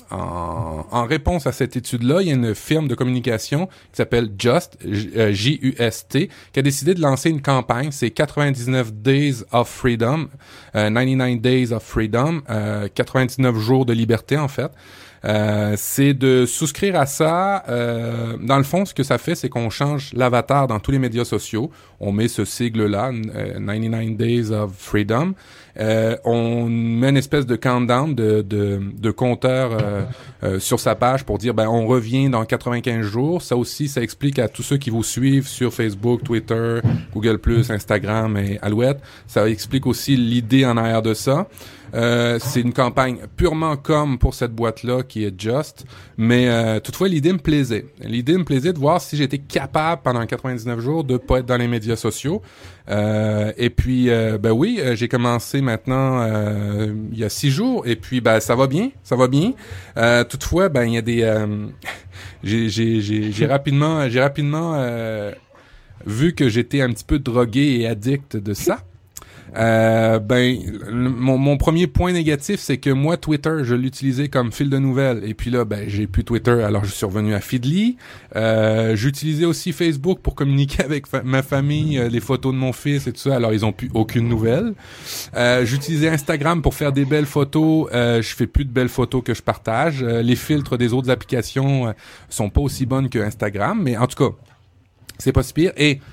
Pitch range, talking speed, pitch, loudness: 110-140 Hz, 190 wpm, 125 Hz, -19 LUFS